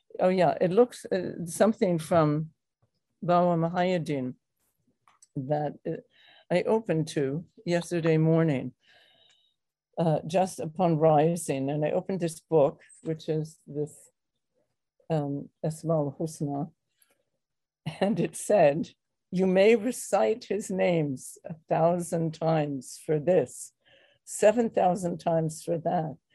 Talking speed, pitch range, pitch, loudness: 110 wpm, 155-180 Hz, 165 Hz, -27 LUFS